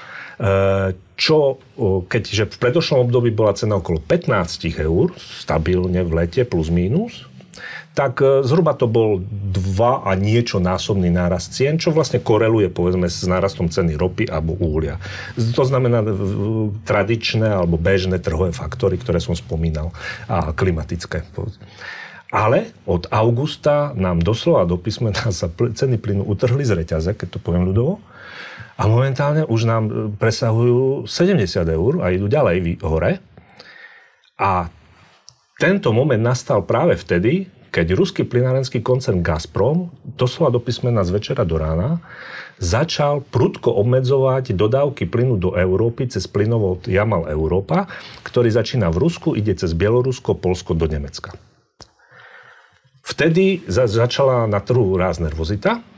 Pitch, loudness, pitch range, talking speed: 110 Hz, -19 LUFS, 90-130 Hz, 130 wpm